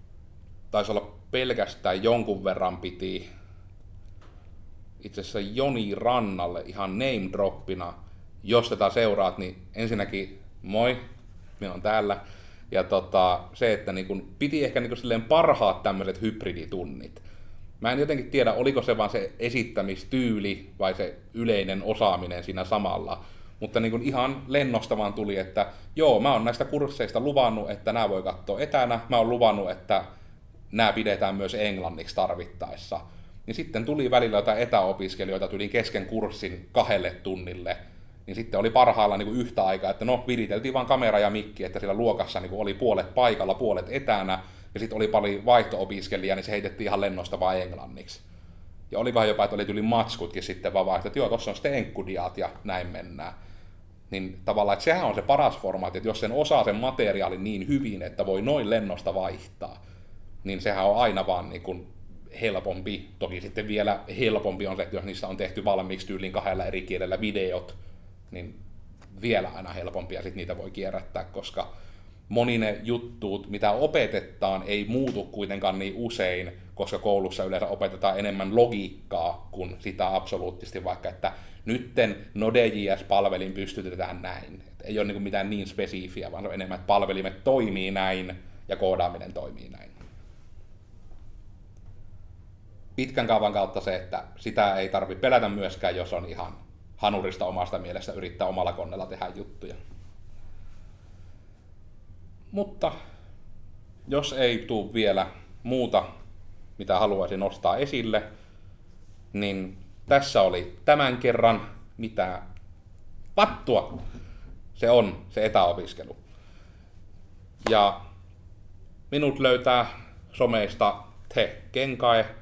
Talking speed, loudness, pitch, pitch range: 140 wpm, -27 LUFS, 95 Hz, 95-110 Hz